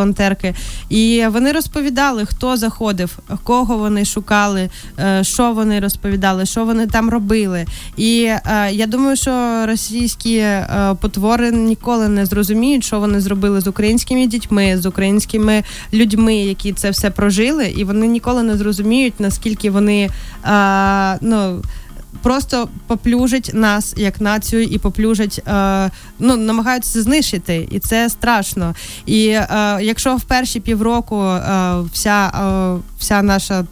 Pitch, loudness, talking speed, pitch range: 215 Hz, -15 LUFS, 120 wpm, 200-230 Hz